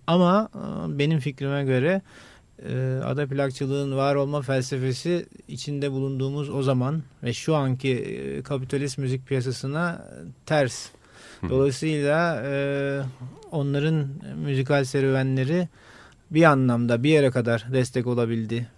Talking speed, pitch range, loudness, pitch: 105 wpm, 130-150 Hz, -25 LUFS, 140 Hz